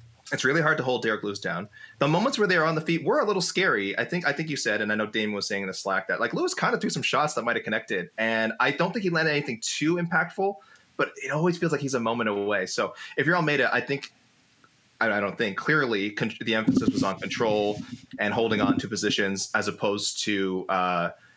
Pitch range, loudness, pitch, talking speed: 105-170 Hz, -26 LUFS, 135 Hz, 260 wpm